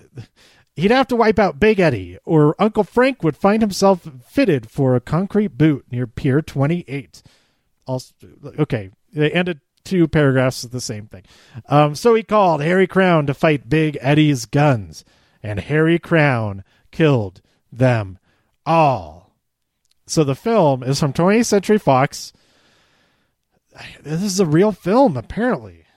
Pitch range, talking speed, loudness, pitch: 130-185 Hz, 145 wpm, -17 LUFS, 150 Hz